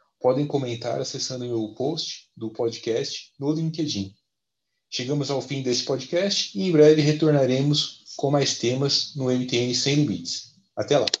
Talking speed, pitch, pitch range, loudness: 150 wpm, 140 Hz, 125-150 Hz, -24 LUFS